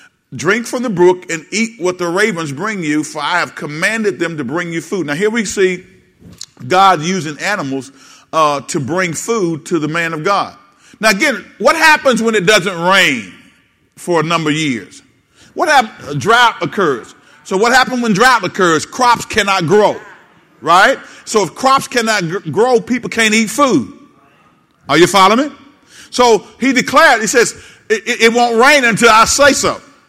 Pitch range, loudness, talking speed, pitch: 170-245 Hz, -12 LUFS, 180 wpm, 210 Hz